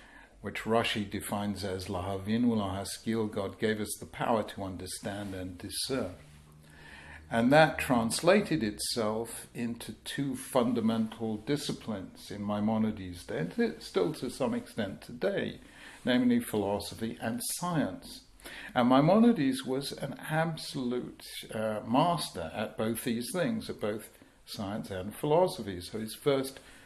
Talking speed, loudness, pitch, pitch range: 120 wpm, -31 LUFS, 110 Hz, 100-125 Hz